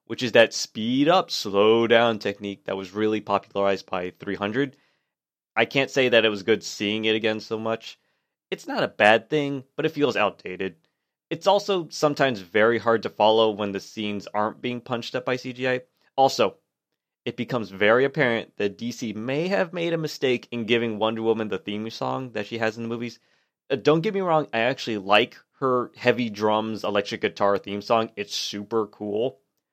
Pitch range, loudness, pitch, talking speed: 105-130 Hz, -24 LUFS, 115 Hz, 190 wpm